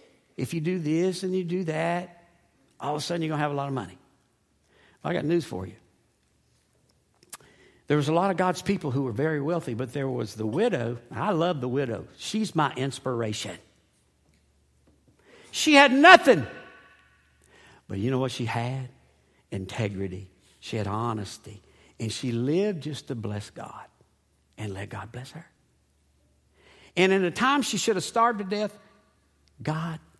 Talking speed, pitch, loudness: 170 wpm, 130 Hz, -25 LUFS